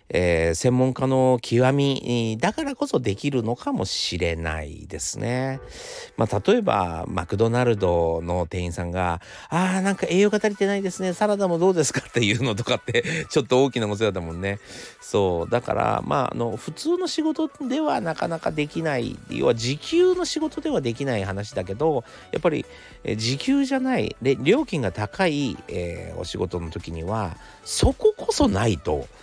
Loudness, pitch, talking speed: -23 LUFS, 125 Hz, 335 characters per minute